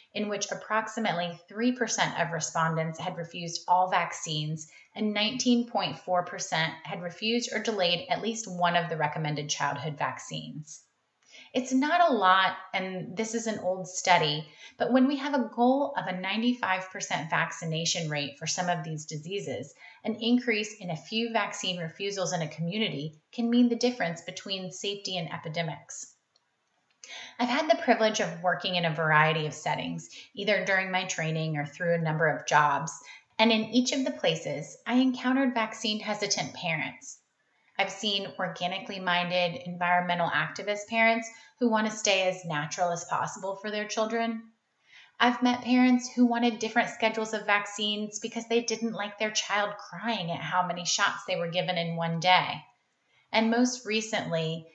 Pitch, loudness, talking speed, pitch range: 190 Hz, -28 LUFS, 160 wpm, 170-225 Hz